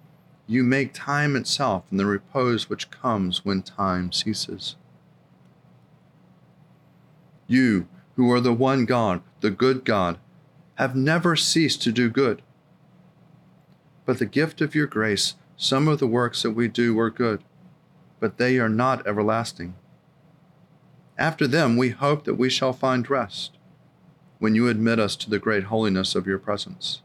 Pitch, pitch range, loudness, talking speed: 130 Hz, 110-155 Hz, -23 LUFS, 150 wpm